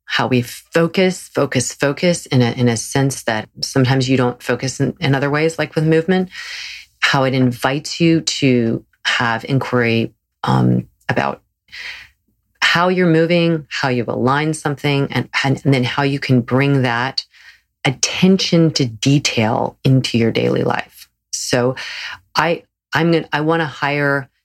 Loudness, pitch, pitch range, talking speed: -17 LUFS, 135 Hz, 125-155 Hz, 150 wpm